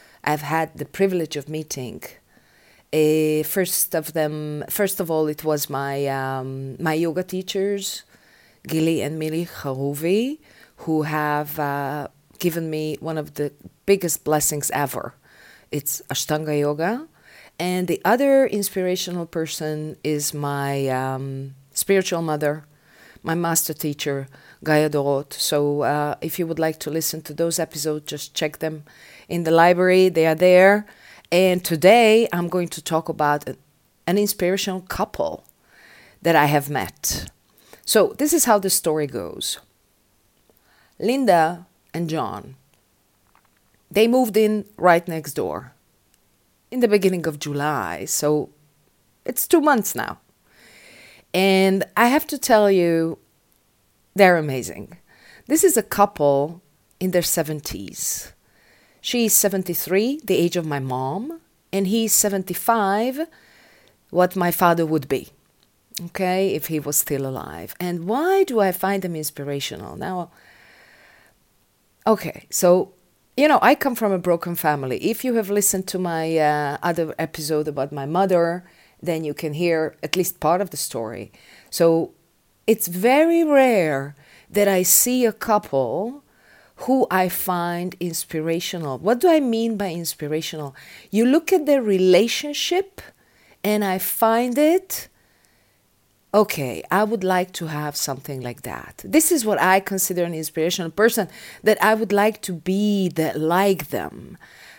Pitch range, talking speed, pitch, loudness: 150-200 Hz, 140 wpm, 170 Hz, -21 LUFS